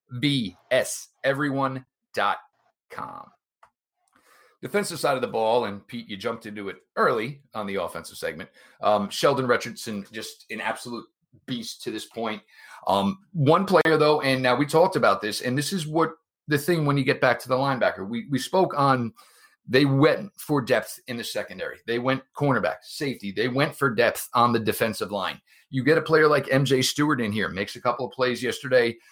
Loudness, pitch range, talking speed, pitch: -24 LUFS, 120-160 Hz, 185 wpm, 135 Hz